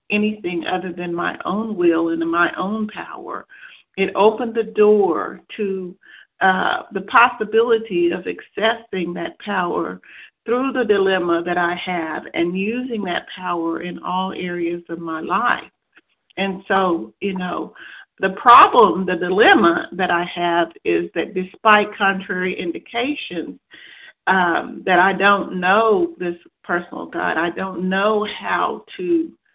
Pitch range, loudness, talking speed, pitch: 175-215 Hz, -19 LUFS, 135 wpm, 190 Hz